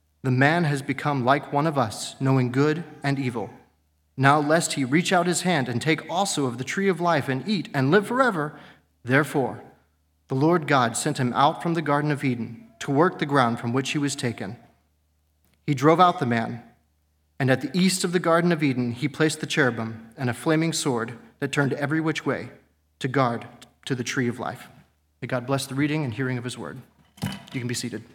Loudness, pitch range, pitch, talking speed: -24 LUFS, 120-155 Hz, 135 Hz, 215 wpm